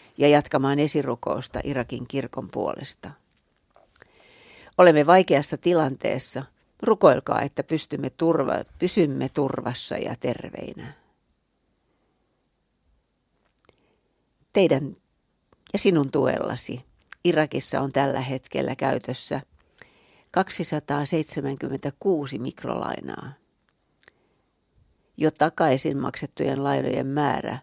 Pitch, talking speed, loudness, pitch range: 145 Hz, 70 wpm, -24 LUFS, 135-155 Hz